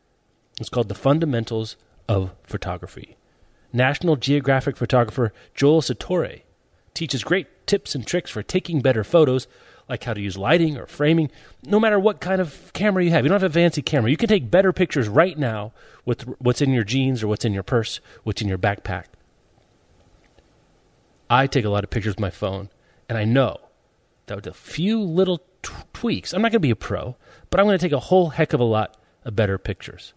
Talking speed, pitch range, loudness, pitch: 205 wpm, 110-165 Hz, -21 LUFS, 130 Hz